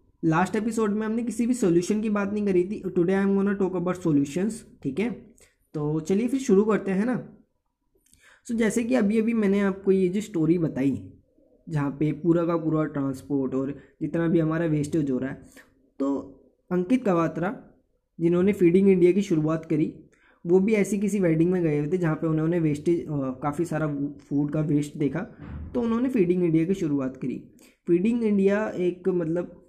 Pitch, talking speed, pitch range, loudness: 175 Hz, 190 wpm, 155-205 Hz, -25 LUFS